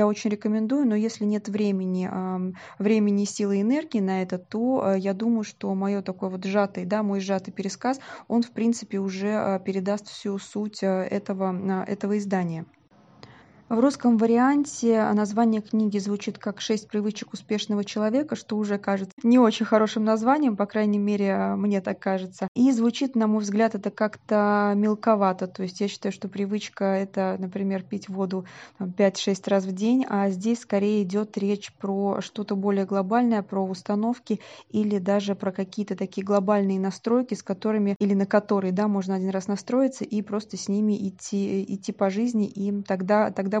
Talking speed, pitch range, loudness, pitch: 165 wpm, 195-215 Hz, -25 LUFS, 205 Hz